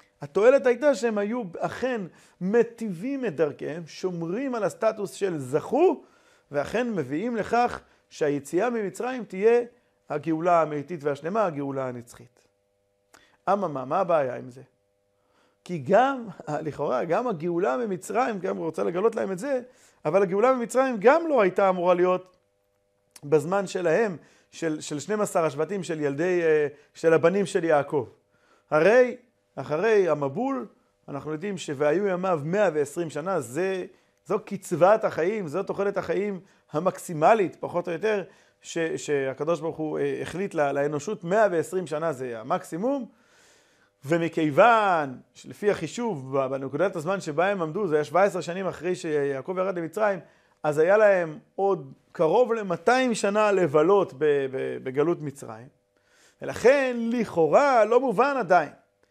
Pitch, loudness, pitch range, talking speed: 180 Hz, -25 LUFS, 150-215 Hz, 125 wpm